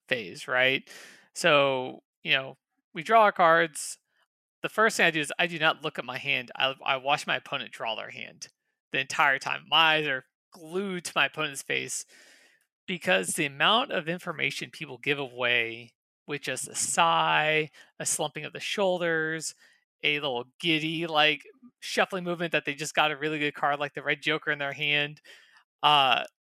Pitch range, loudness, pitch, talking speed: 145-170 Hz, -26 LUFS, 155 Hz, 180 wpm